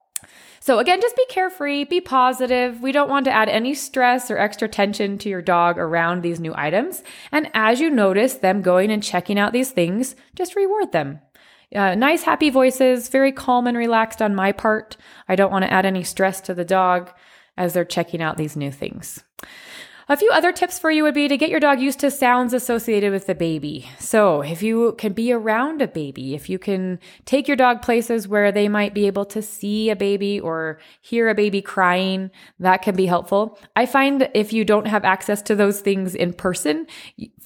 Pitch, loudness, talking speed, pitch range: 210 Hz, -19 LUFS, 210 wpm, 185-260 Hz